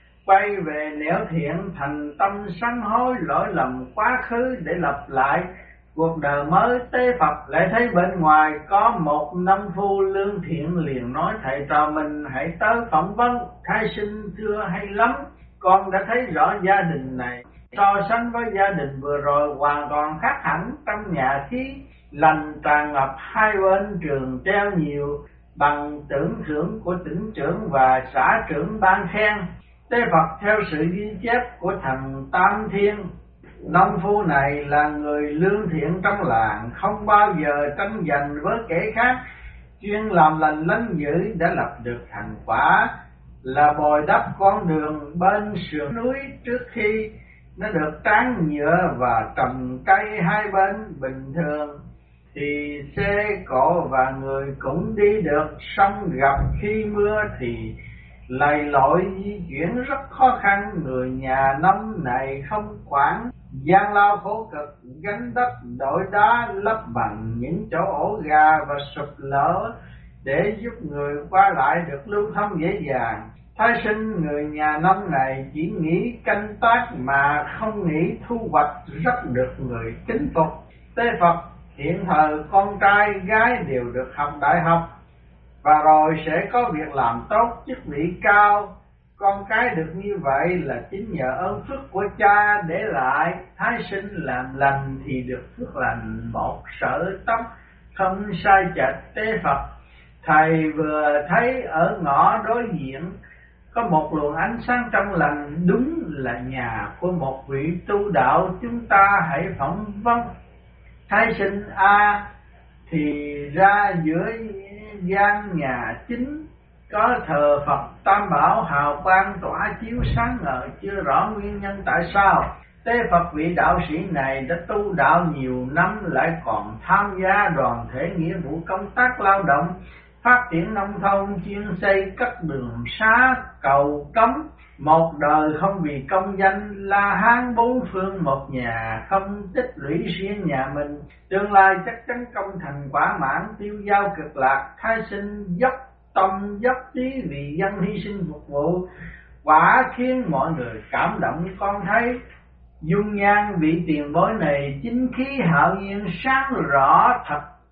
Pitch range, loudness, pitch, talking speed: 145-205 Hz, -21 LUFS, 180 Hz, 160 wpm